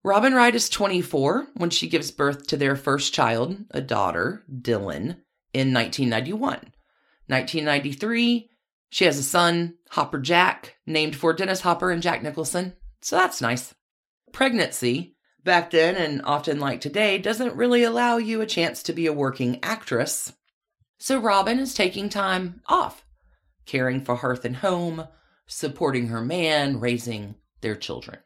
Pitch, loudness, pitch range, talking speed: 160 Hz, -23 LUFS, 130-195 Hz, 145 wpm